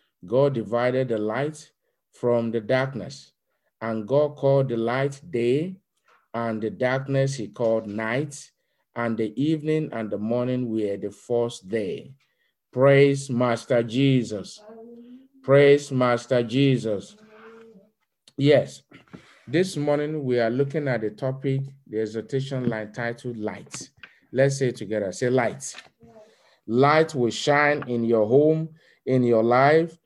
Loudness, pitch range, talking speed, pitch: -23 LUFS, 115-145 Hz, 130 wpm, 130 Hz